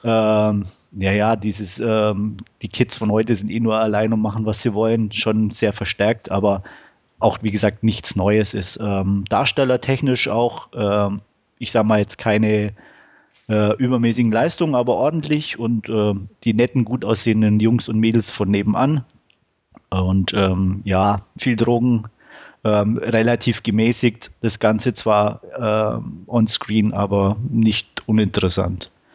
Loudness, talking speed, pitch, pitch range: -19 LUFS, 145 wpm, 110 Hz, 105-115 Hz